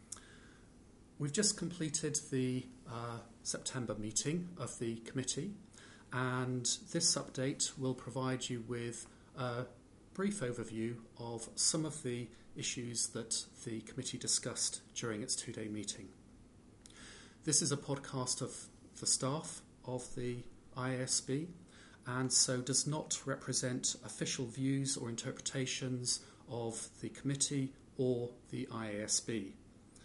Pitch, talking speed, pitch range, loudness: 125 Hz, 120 wpm, 115-135 Hz, -37 LUFS